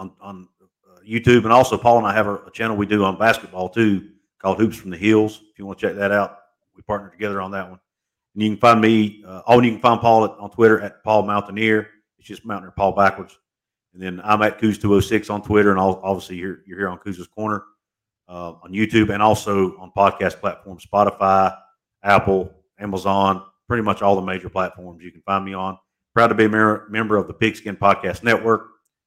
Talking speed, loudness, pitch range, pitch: 220 wpm, -19 LUFS, 95-110 Hz, 100 Hz